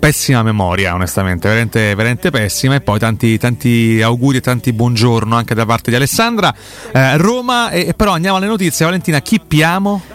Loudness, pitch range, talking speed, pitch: -13 LUFS, 115-170 Hz, 170 wpm, 125 Hz